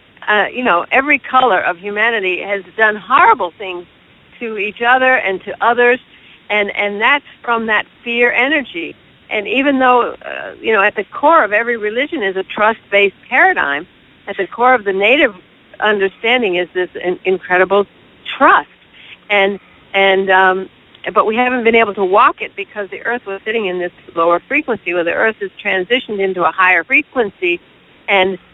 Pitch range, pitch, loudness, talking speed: 190-250 Hz, 210 Hz, -14 LUFS, 175 wpm